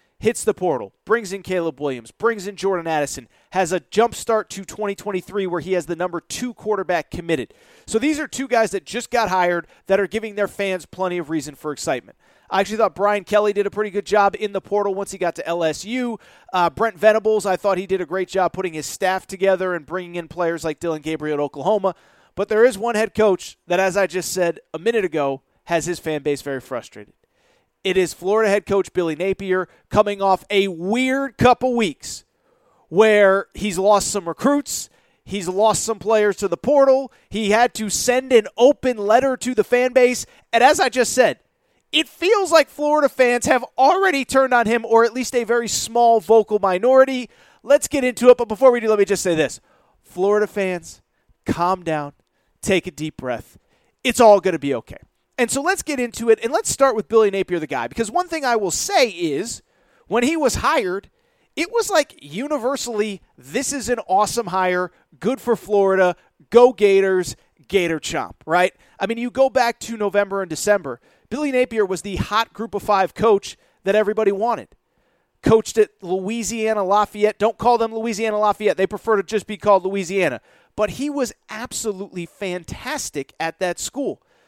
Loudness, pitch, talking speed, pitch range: -20 LUFS, 205 Hz, 195 wpm, 185-235 Hz